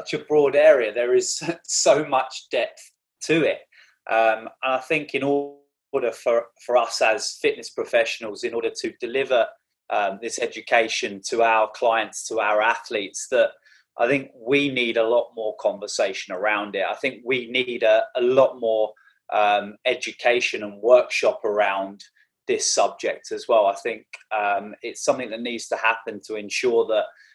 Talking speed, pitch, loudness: 165 wpm, 135 Hz, -22 LUFS